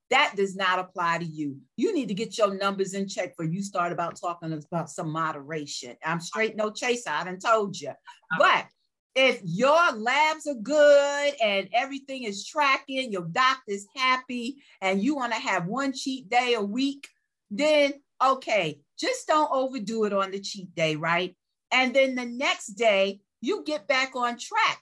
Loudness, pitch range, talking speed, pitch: -26 LUFS, 185-275 Hz, 175 wpm, 225 Hz